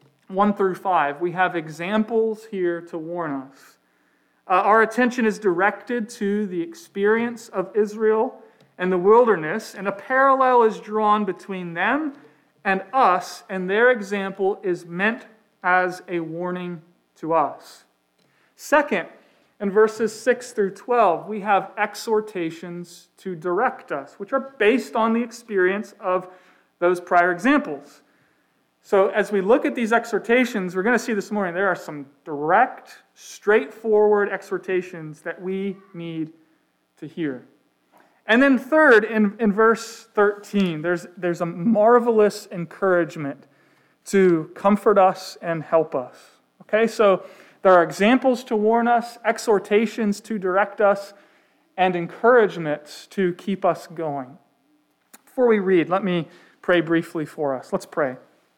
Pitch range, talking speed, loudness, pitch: 175-220 Hz, 140 wpm, -21 LUFS, 200 Hz